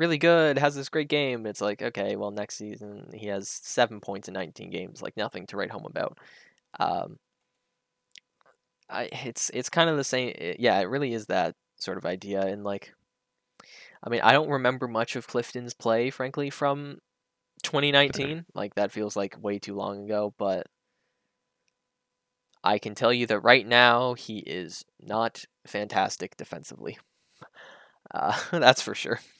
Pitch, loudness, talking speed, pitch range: 120 Hz, -27 LUFS, 165 wpm, 105-140 Hz